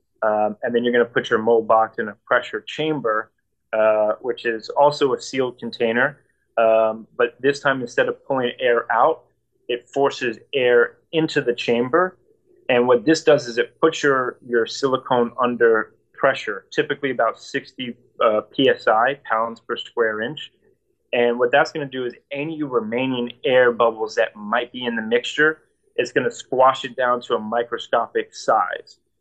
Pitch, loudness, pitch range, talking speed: 125 Hz, -20 LUFS, 115-155 Hz, 175 wpm